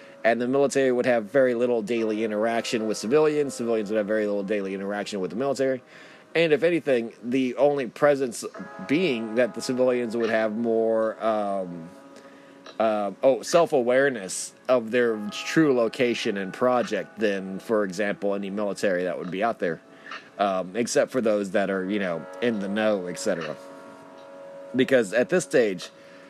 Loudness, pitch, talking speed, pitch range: -25 LUFS, 115 Hz, 160 wpm, 100-125 Hz